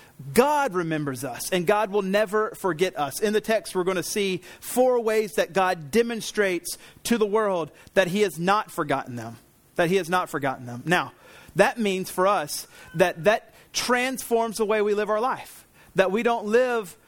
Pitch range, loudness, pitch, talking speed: 170-215 Hz, -24 LUFS, 195 Hz, 190 wpm